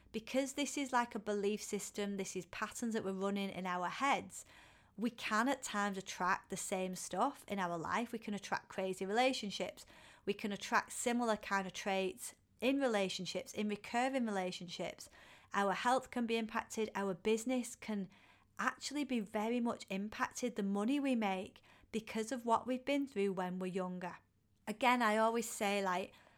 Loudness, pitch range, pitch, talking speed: -38 LUFS, 195-240 Hz, 210 Hz, 170 wpm